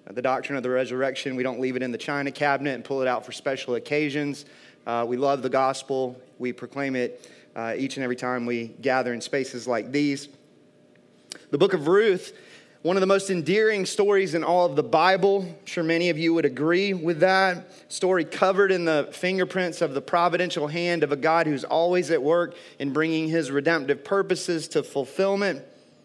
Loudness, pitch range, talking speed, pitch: -24 LUFS, 130-180 Hz, 200 wpm, 150 Hz